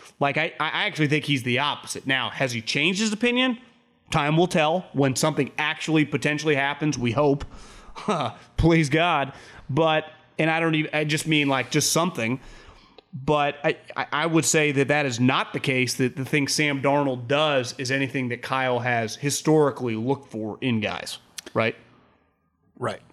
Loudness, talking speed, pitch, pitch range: -23 LUFS, 170 wpm, 145 Hz, 135-155 Hz